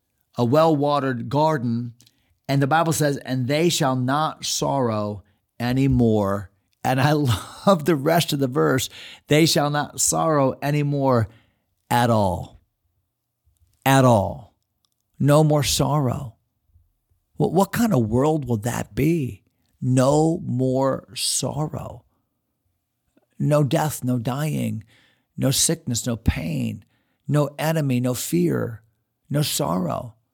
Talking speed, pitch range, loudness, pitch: 115 wpm, 115-150 Hz, -21 LUFS, 130 Hz